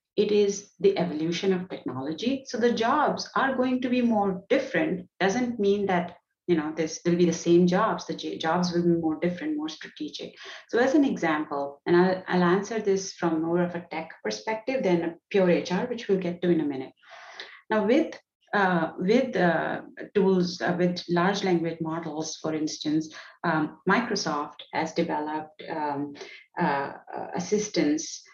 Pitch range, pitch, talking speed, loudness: 165-210 Hz, 180 Hz, 170 wpm, -26 LUFS